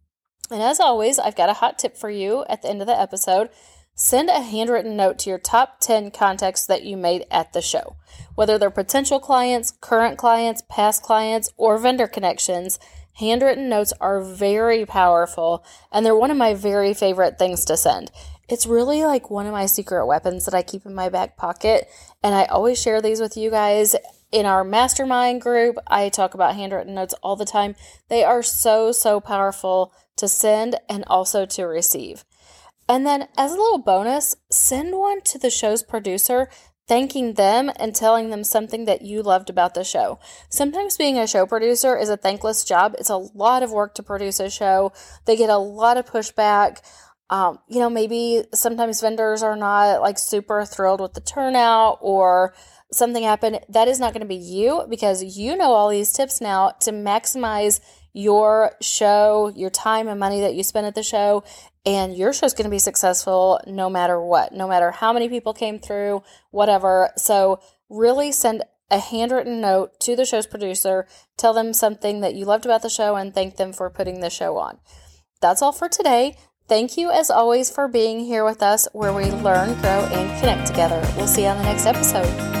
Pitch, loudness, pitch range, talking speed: 210 Hz, -19 LUFS, 195-230 Hz, 195 wpm